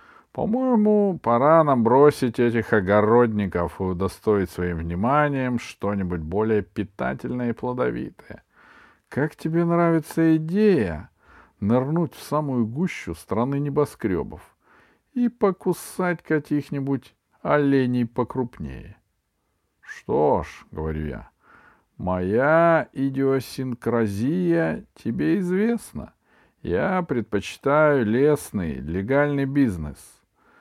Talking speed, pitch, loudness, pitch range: 85 wpm, 130 Hz, -23 LUFS, 105-160 Hz